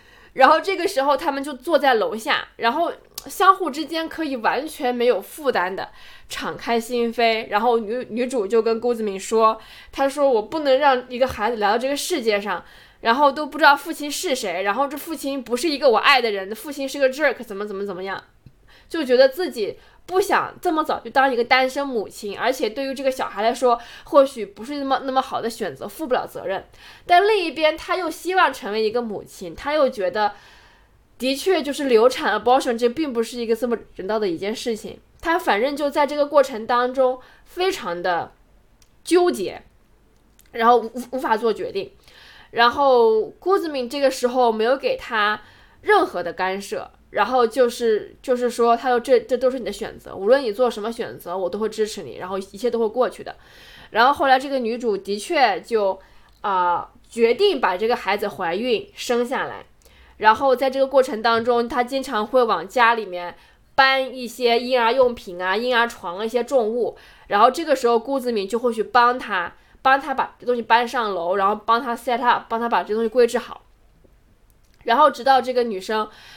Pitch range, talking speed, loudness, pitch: 230-290 Hz, 300 characters per minute, -21 LUFS, 250 Hz